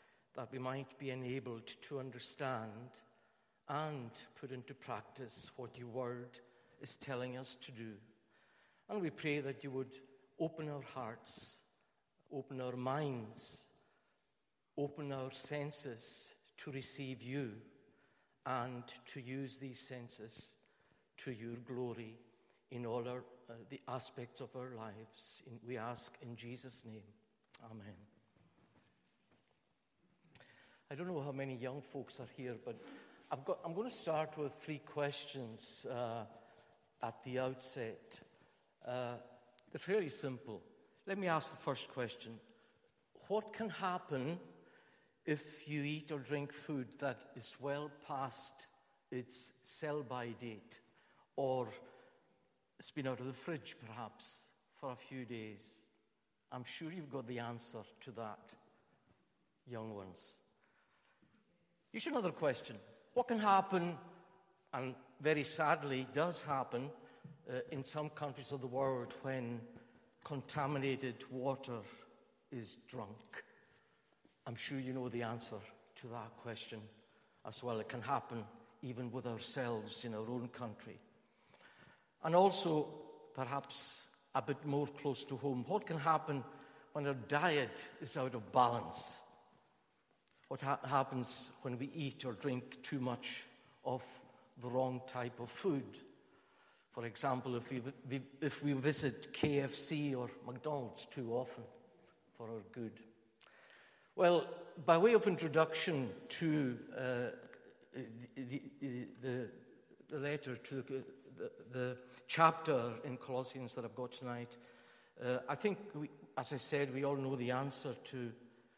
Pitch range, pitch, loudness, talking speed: 120-145 Hz, 130 Hz, -42 LUFS, 130 wpm